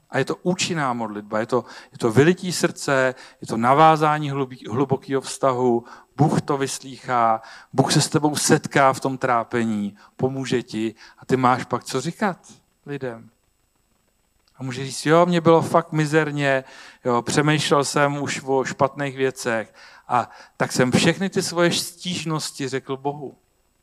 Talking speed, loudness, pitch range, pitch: 150 wpm, -21 LUFS, 125-155 Hz, 135 Hz